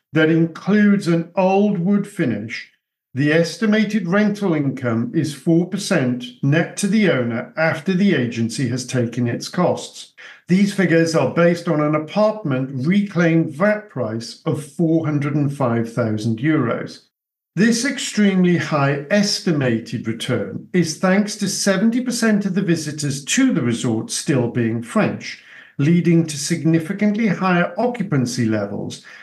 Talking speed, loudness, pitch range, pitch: 125 wpm, -19 LUFS, 130-195 Hz, 165 Hz